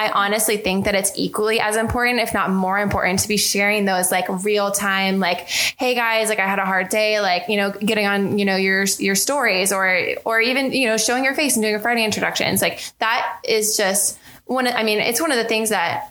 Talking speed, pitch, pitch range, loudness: 240 wpm, 210 Hz, 195-225 Hz, -18 LUFS